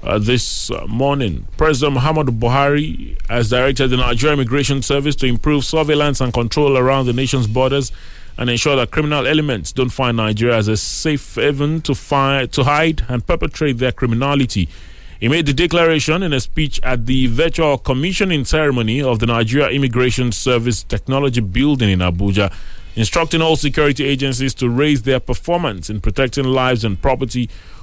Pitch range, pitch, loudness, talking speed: 120-145 Hz, 130 Hz, -16 LUFS, 160 wpm